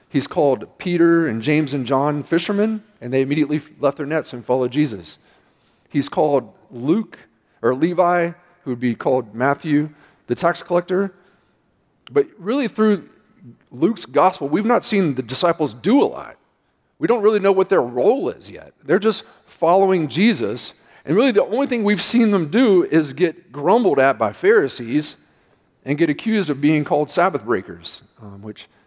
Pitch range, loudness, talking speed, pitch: 145-205 Hz, -19 LUFS, 170 wpm, 170 Hz